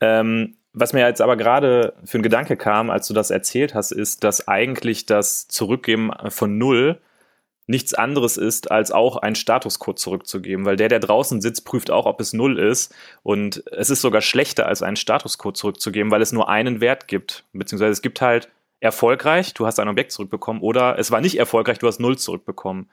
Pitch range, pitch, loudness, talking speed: 105-125 Hz, 115 Hz, -19 LUFS, 195 wpm